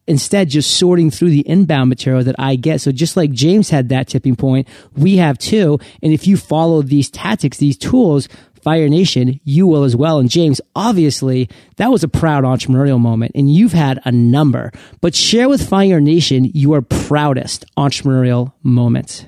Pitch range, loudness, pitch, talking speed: 130-165 Hz, -13 LUFS, 145 Hz, 180 wpm